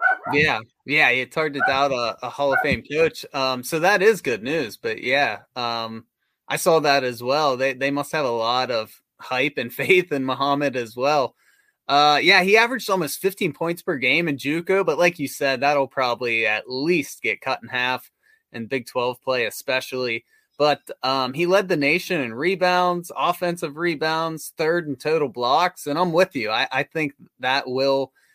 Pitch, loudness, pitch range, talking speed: 145 Hz, -21 LUFS, 130-180 Hz, 195 wpm